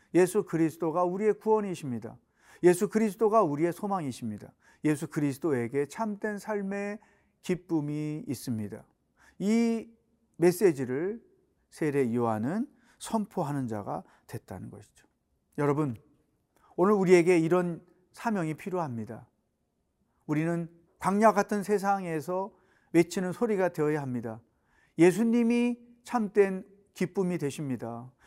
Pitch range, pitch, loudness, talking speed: 145-210 Hz, 180 Hz, -29 LUFS, 270 characters per minute